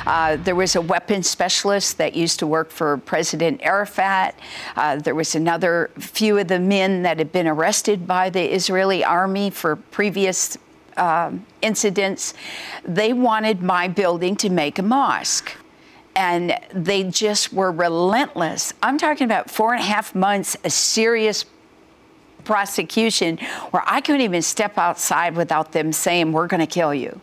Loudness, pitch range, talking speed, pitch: -19 LUFS, 170-205 Hz, 155 wpm, 190 Hz